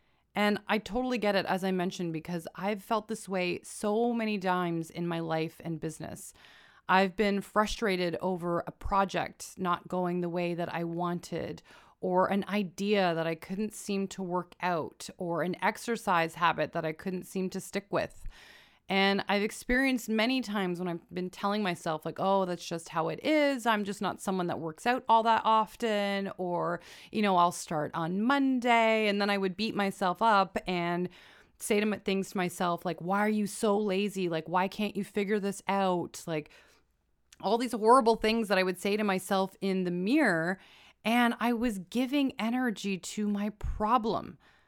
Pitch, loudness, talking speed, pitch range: 190 Hz, -30 LUFS, 185 wpm, 175-210 Hz